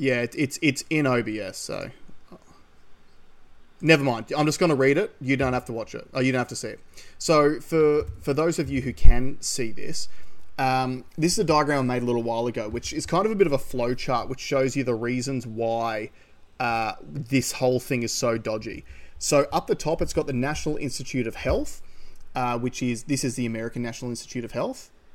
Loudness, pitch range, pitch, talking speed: -25 LUFS, 120-145 Hz, 130 Hz, 225 wpm